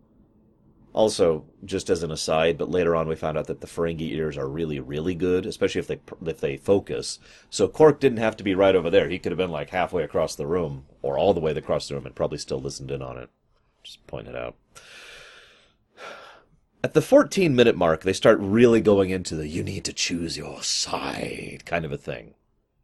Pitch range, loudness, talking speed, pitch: 75-100 Hz, -24 LUFS, 215 wpm, 85 Hz